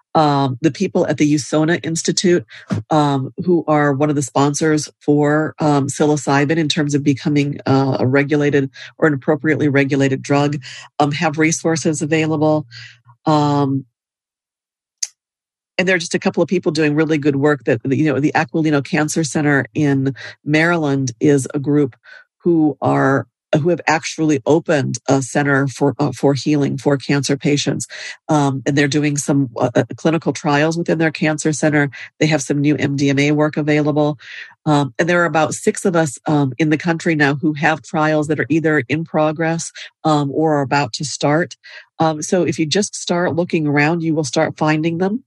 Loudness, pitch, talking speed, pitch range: -17 LUFS, 150 Hz, 170 wpm, 145-160 Hz